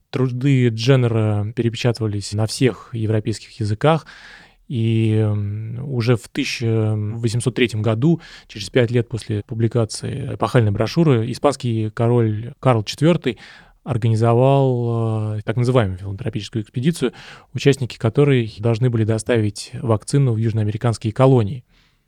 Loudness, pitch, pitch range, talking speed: -19 LUFS, 115 Hz, 110-130 Hz, 100 wpm